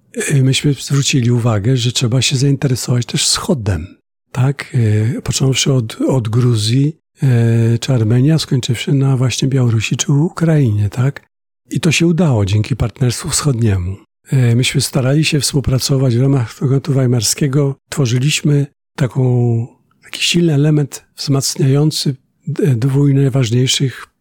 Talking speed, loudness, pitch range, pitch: 110 wpm, -14 LUFS, 125-145 Hz, 135 Hz